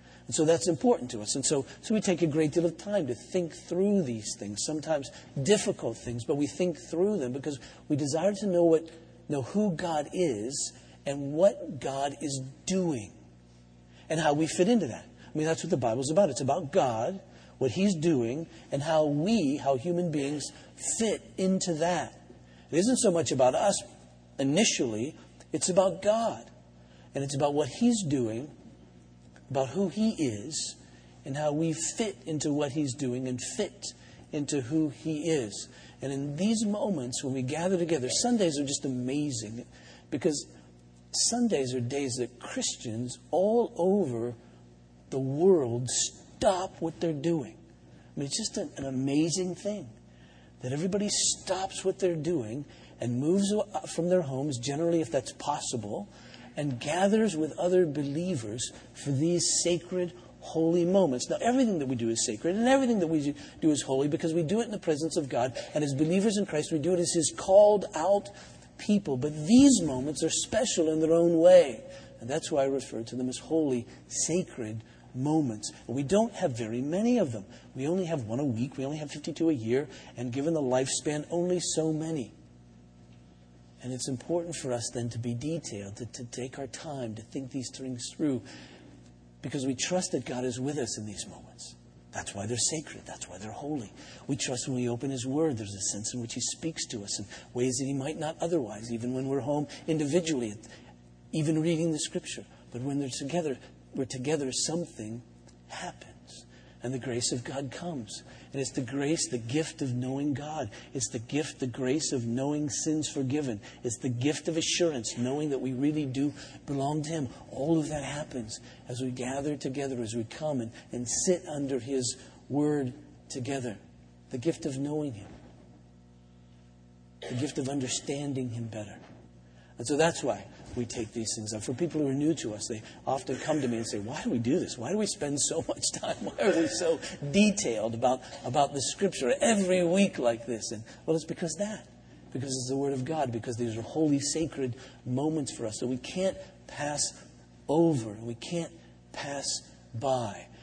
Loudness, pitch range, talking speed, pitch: -30 LUFS, 120-165 Hz, 185 wpm, 140 Hz